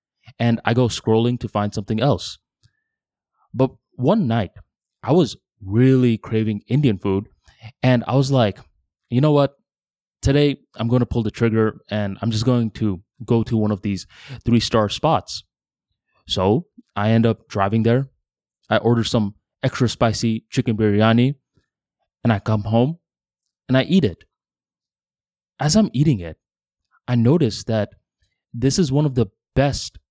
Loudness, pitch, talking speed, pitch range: -20 LUFS, 115 Hz, 155 wpm, 105-130 Hz